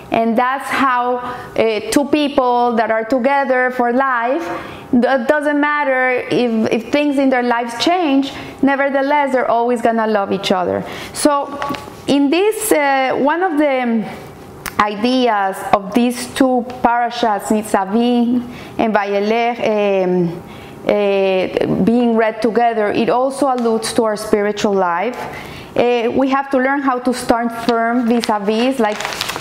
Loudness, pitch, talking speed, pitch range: -16 LUFS, 240 Hz, 140 wpm, 220-270 Hz